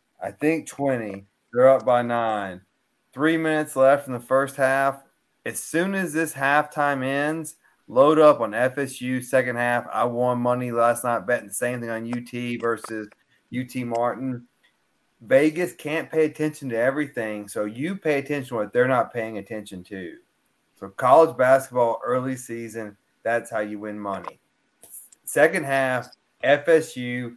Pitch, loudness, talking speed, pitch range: 125 Hz, -23 LUFS, 155 wpm, 115-145 Hz